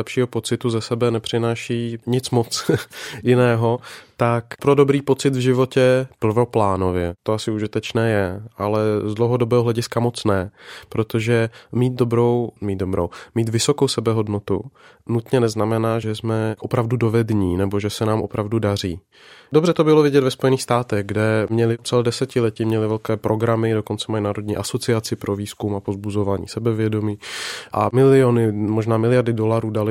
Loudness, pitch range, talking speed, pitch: -20 LUFS, 105-120 Hz, 145 wpm, 115 Hz